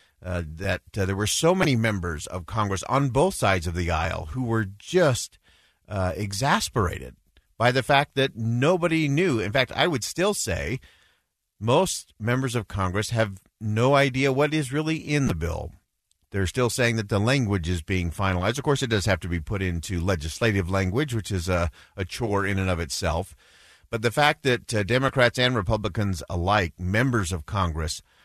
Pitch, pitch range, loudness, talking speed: 105 Hz, 90-130 Hz, -25 LUFS, 185 wpm